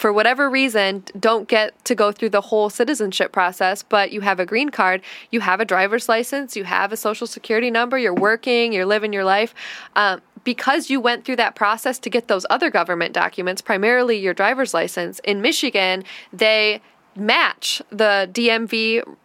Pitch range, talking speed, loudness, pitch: 200-235 Hz, 180 wpm, -19 LUFS, 220 Hz